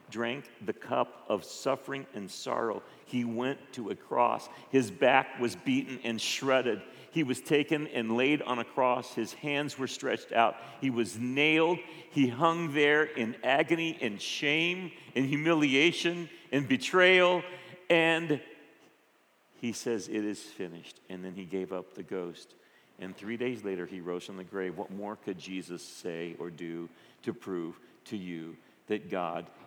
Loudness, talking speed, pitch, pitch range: -30 LUFS, 160 wpm, 125 Hz, 105-150 Hz